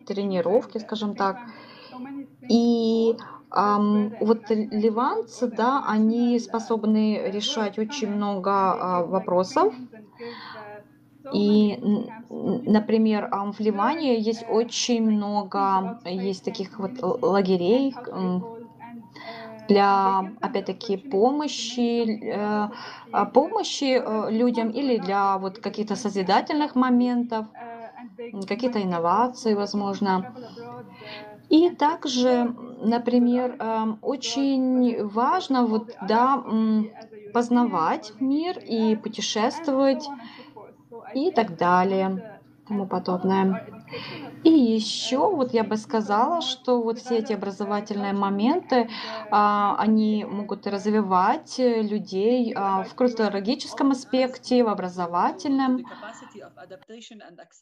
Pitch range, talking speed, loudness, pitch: 205-245 Hz, 80 wpm, -24 LUFS, 225 Hz